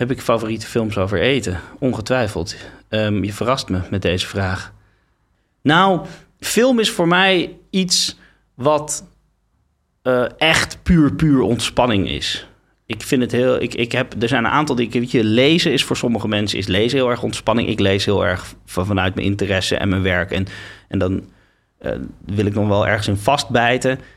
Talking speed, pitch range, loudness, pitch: 180 wpm, 100-130 Hz, -18 LUFS, 115 Hz